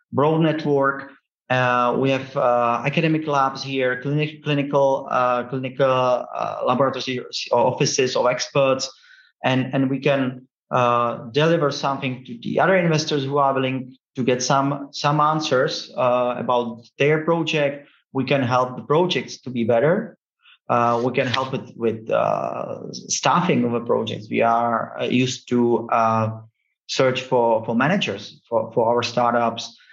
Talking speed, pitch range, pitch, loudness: 145 wpm, 120-140 Hz, 130 Hz, -21 LUFS